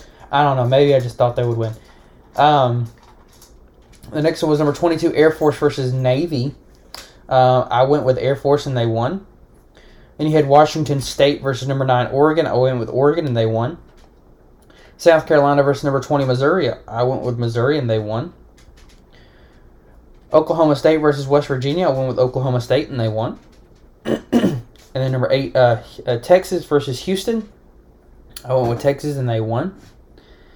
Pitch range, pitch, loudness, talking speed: 110-145 Hz, 130 Hz, -17 LUFS, 175 wpm